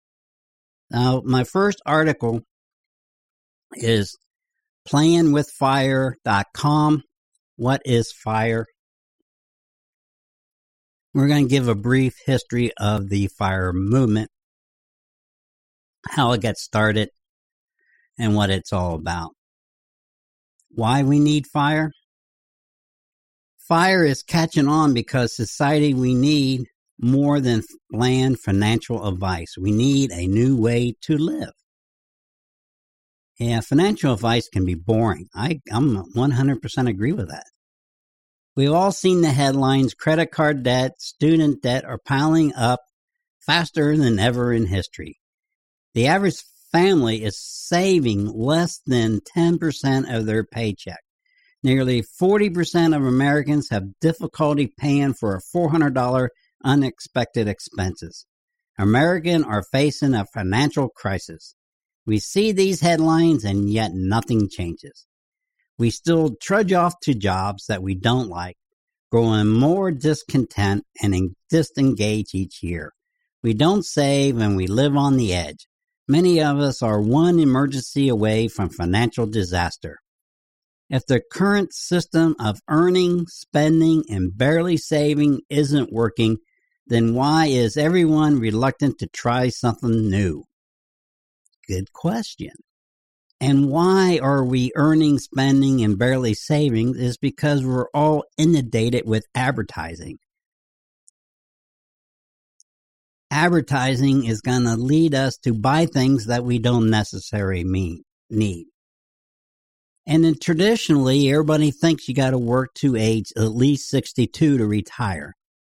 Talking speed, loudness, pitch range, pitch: 120 wpm, -20 LUFS, 110-155 Hz, 130 Hz